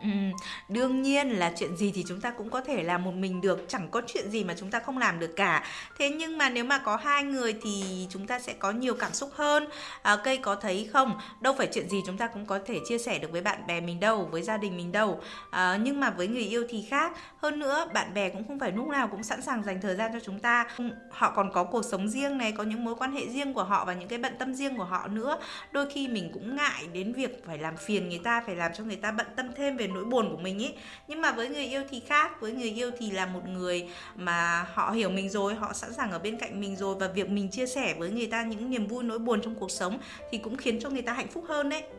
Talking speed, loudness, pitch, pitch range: 285 wpm, -30 LUFS, 225 Hz, 195-260 Hz